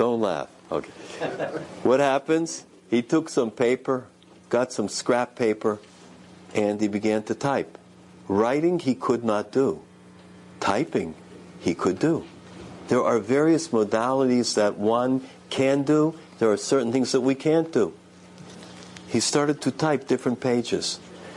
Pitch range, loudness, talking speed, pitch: 105-135 Hz, -24 LUFS, 140 wpm, 120 Hz